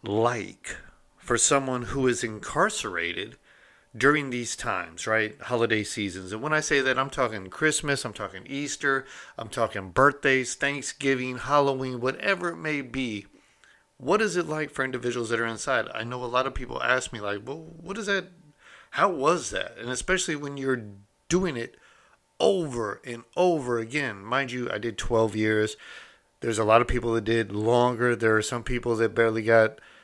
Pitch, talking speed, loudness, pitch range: 125 Hz, 175 wpm, -26 LUFS, 115-140 Hz